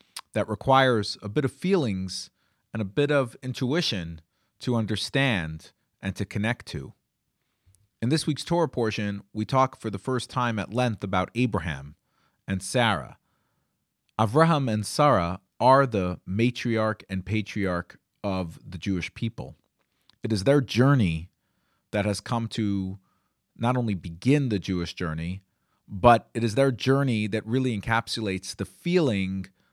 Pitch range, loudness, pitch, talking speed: 95-125 Hz, -26 LUFS, 110 Hz, 140 wpm